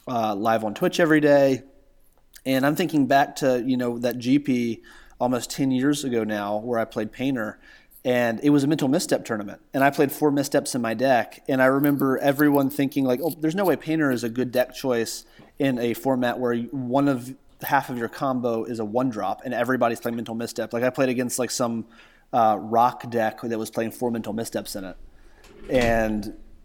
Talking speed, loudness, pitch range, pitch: 205 wpm, -23 LUFS, 115-140 Hz, 125 Hz